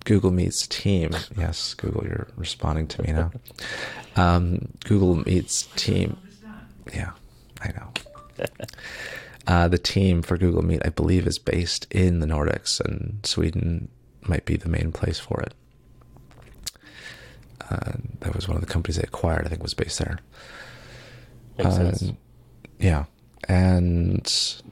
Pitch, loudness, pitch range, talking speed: 95 Hz, -25 LUFS, 85-110 Hz, 135 wpm